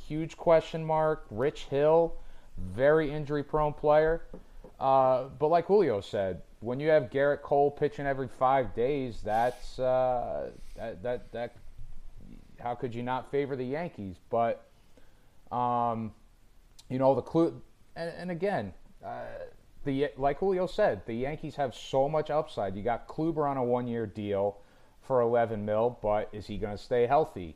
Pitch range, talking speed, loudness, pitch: 115-150 Hz, 155 wpm, -29 LUFS, 130 Hz